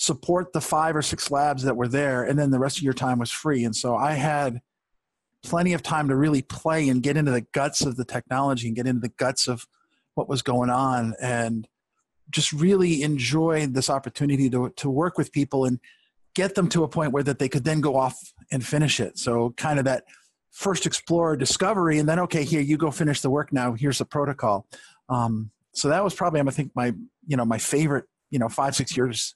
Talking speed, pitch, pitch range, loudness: 225 wpm, 140 Hz, 125-155 Hz, -24 LUFS